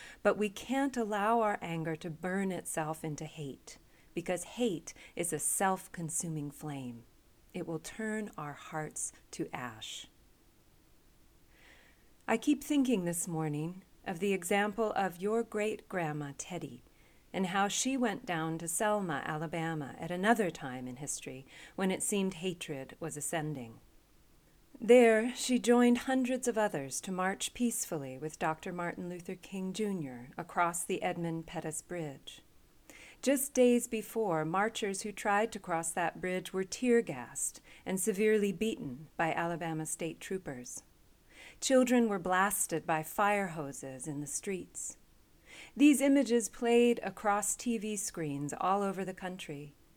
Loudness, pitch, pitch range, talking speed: -33 LUFS, 185 Hz, 160-215 Hz, 140 wpm